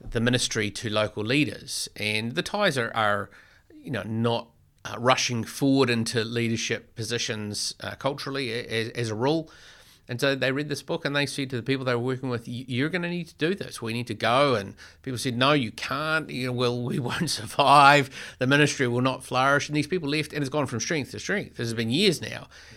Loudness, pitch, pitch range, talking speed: -25 LUFS, 125 Hz, 115-140 Hz, 225 wpm